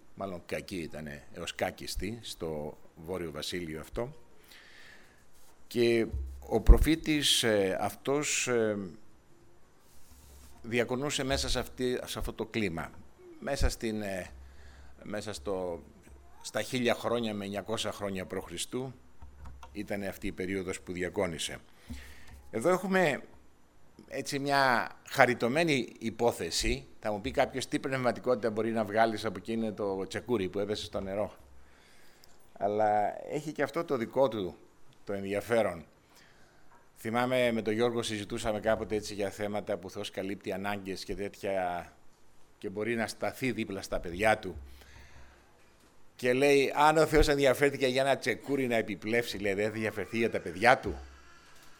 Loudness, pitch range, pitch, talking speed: -31 LUFS, 90-120 Hz, 105 Hz, 125 wpm